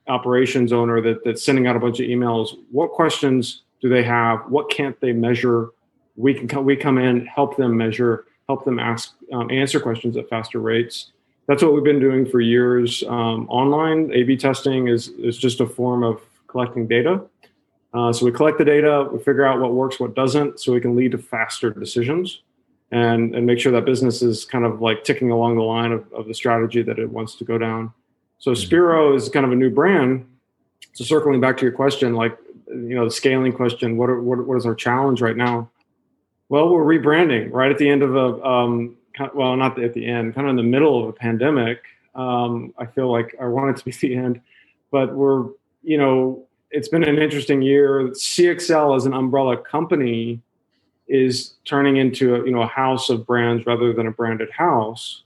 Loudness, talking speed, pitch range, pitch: -19 LUFS, 215 wpm, 120-135 Hz, 125 Hz